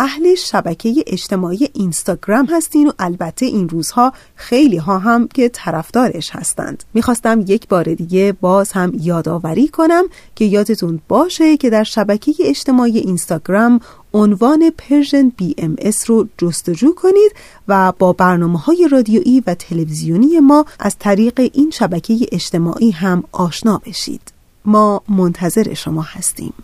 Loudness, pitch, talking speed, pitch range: -14 LUFS, 210 Hz, 130 wpm, 180-255 Hz